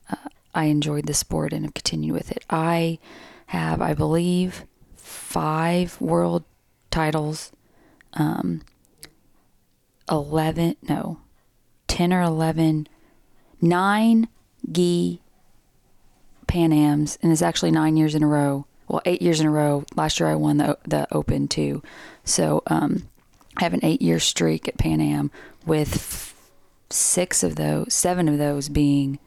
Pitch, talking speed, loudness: 150 Hz, 135 wpm, -22 LUFS